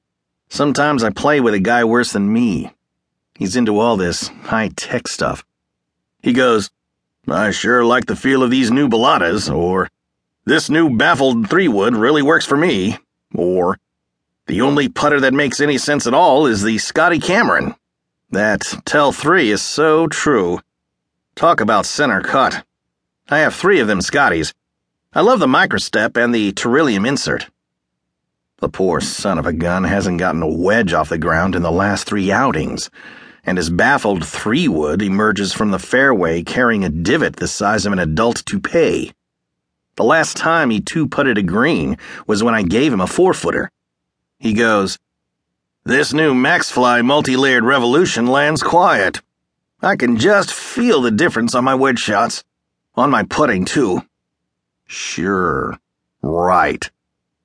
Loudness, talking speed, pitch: -15 LUFS, 155 wpm, 90 Hz